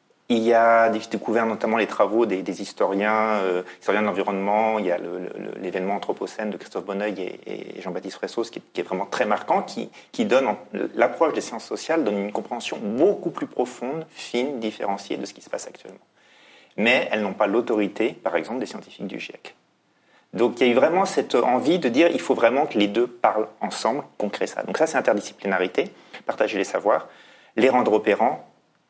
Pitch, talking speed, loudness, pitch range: 110 Hz, 205 wpm, -23 LUFS, 100-115 Hz